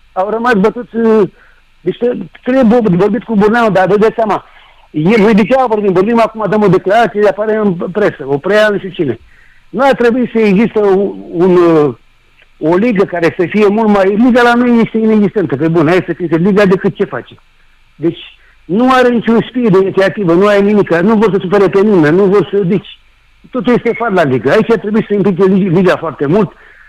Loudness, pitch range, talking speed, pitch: -10 LUFS, 185-225 Hz, 200 wpm, 205 Hz